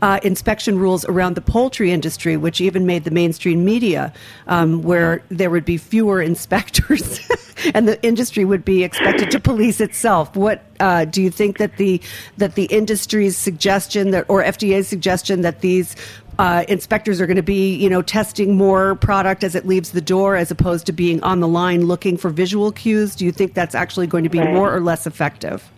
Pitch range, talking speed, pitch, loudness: 175-200 Hz, 200 wpm, 190 Hz, -17 LUFS